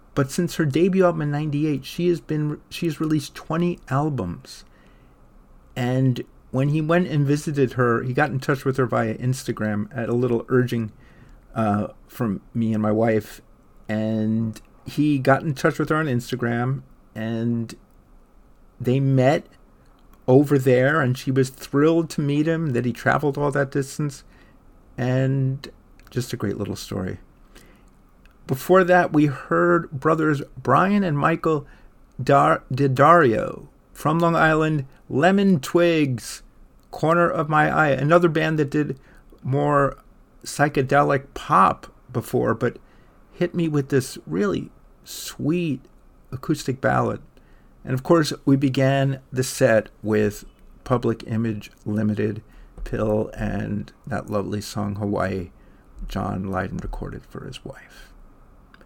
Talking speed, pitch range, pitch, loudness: 135 wpm, 115-150 Hz, 135 Hz, -22 LUFS